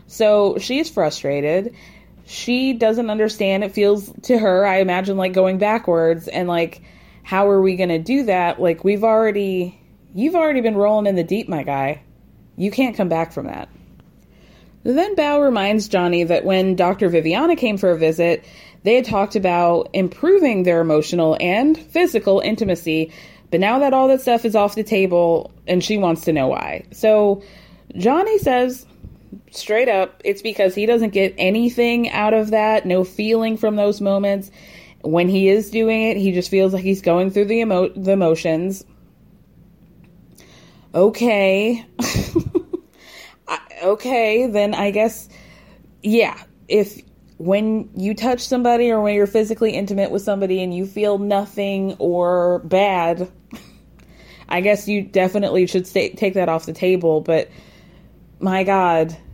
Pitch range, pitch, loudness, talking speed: 180-220 Hz, 200 Hz, -18 LUFS, 155 wpm